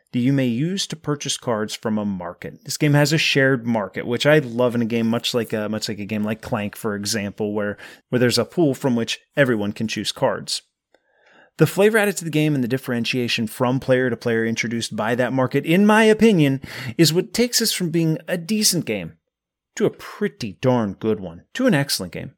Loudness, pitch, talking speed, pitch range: -20 LUFS, 125 Hz, 220 wpm, 110-155 Hz